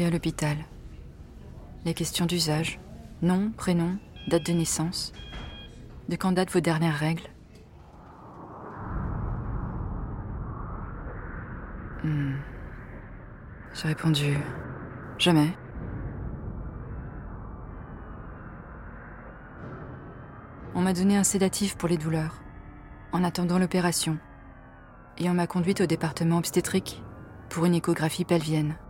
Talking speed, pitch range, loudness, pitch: 85 wpm, 130-175 Hz, -28 LUFS, 160 Hz